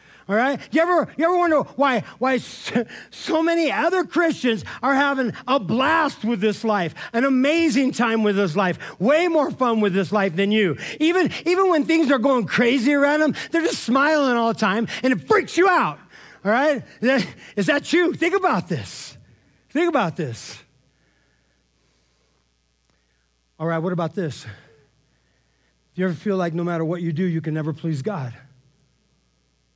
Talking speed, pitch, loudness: 175 wpm, 230 Hz, -21 LUFS